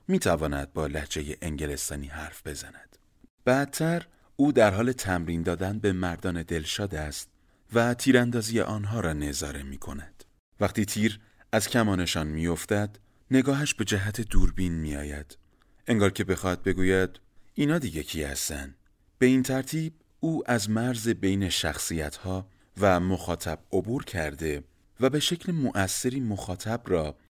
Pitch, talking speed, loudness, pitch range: 95 Hz, 140 wpm, -28 LUFS, 80-115 Hz